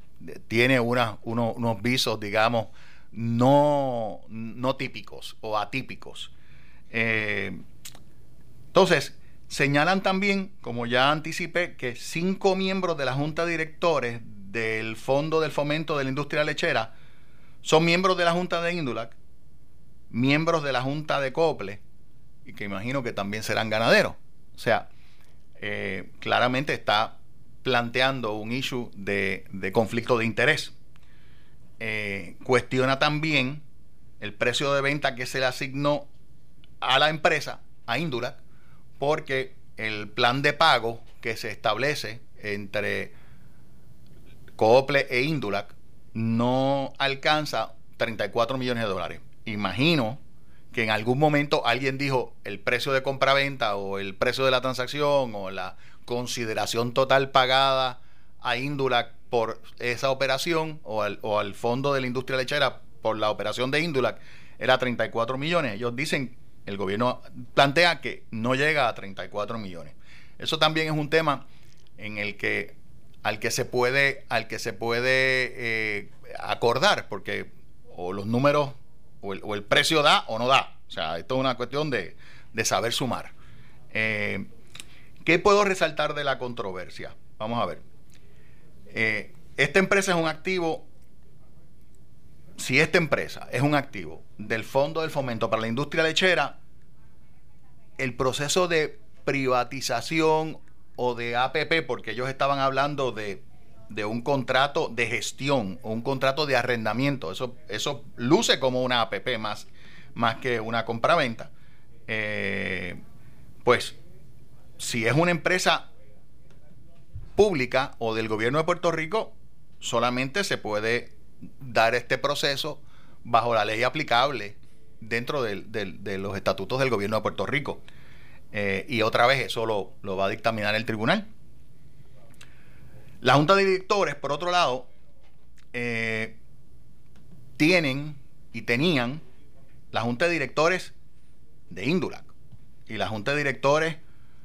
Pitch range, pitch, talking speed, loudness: 115-145 Hz, 130 Hz, 135 wpm, -25 LUFS